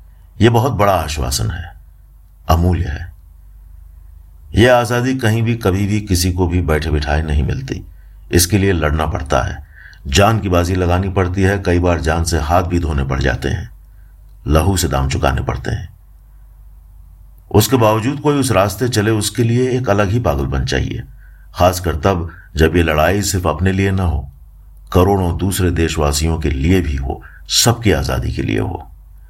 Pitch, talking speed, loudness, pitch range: 90 Hz, 170 wpm, -16 LUFS, 80-100 Hz